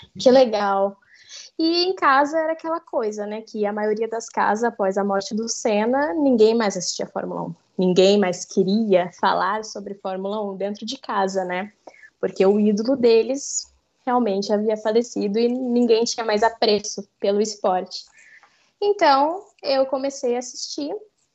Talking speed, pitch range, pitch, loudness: 155 wpm, 200-270 Hz, 220 Hz, -21 LUFS